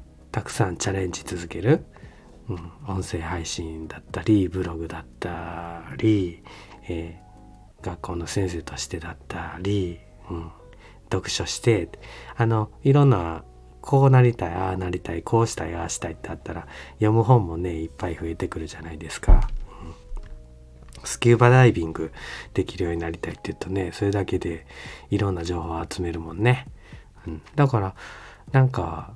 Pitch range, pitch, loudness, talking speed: 80-105 Hz, 90 Hz, -24 LUFS, 325 characters per minute